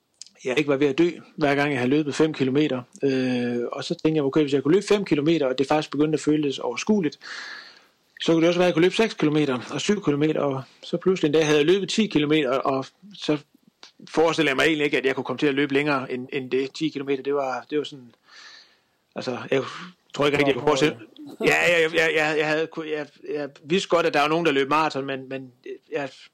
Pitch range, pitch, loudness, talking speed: 140-165 Hz, 150 Hz, -23 LUFS, 250 wpm